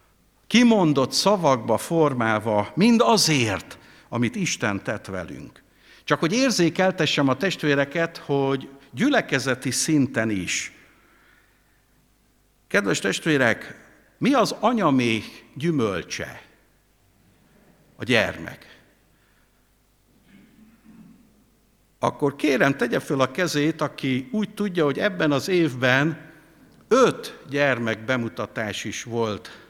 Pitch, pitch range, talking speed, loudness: 145 Hz, 125-180 Hz, 90 wpm, -22 LUFS